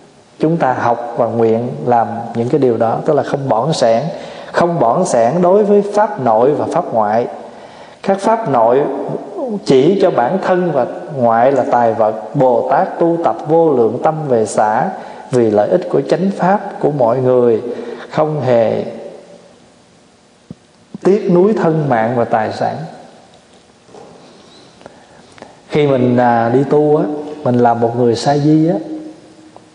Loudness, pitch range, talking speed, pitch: -14 LUFS, 115-175 Hz, 155 wpm, 135 Hz